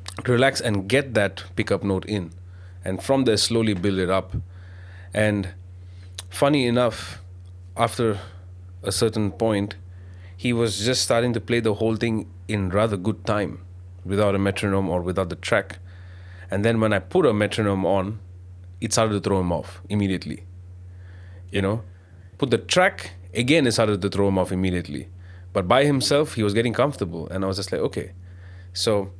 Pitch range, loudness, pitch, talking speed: 90-110 Hz, -23 LUFS, 95 Hz, 170 wpm